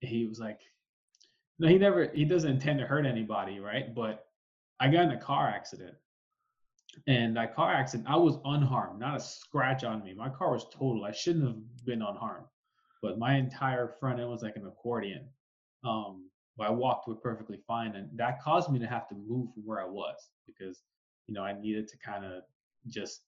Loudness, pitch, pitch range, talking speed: -32 LUFS, 120 Hz, 110-150 Hz, 200 wpm